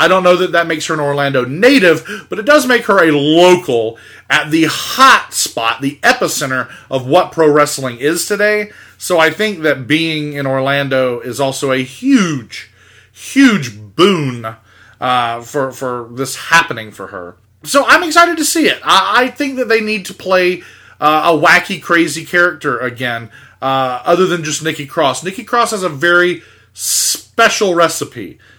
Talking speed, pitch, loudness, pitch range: 170 wpm, 155 Hz, -12 LUFS, 130-185 Hz